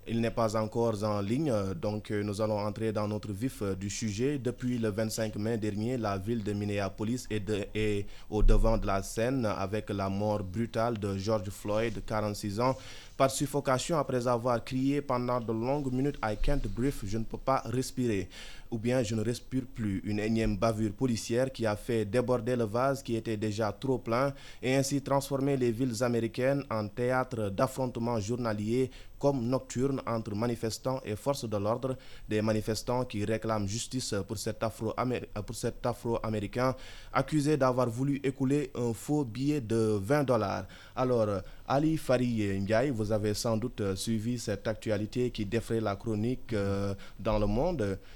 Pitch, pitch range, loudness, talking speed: 115 Hz, 105-130 Hz, -31 LUFS, 170 wpm